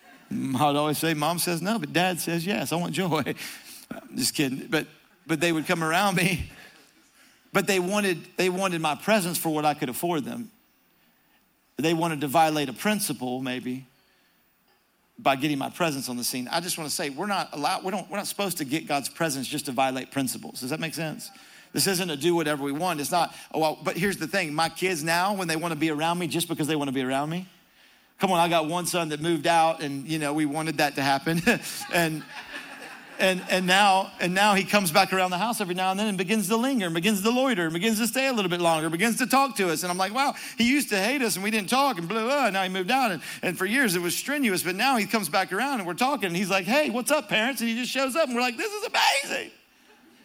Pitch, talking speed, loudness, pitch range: 180 Hz, 260 wpm, -25 LUFS, 160-215 Hz